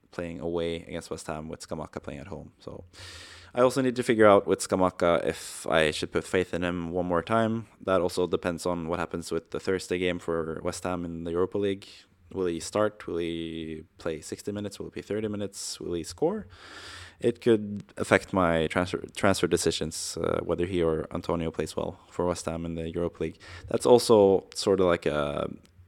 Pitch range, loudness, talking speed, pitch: 85-100 Hz, -28 LUFS, 205 wpm, 90 Hz